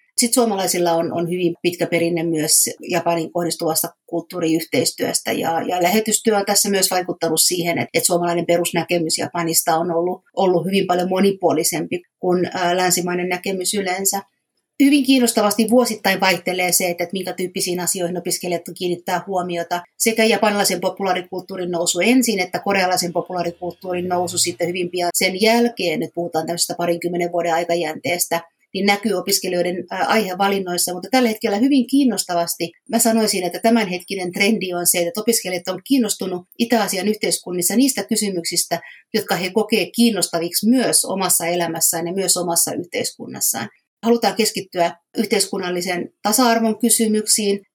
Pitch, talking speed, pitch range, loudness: 180 Hz, 135 wpm, 175-205 Hz, -19 LUFS